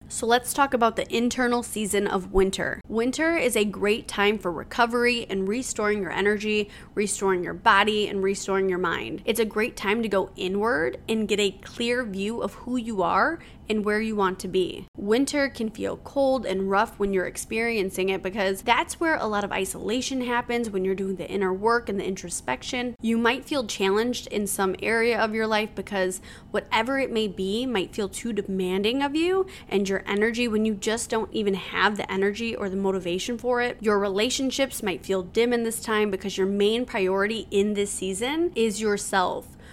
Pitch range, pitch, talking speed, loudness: 195-235 Hz, 210 Hz, 195 wpm, -25 LUFS